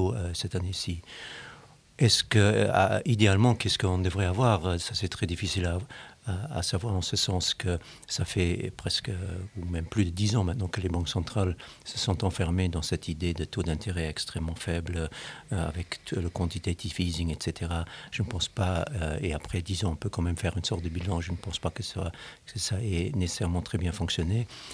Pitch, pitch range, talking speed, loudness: 90 Hz, 85-105 Hz, 210 wpm, -29 LUFS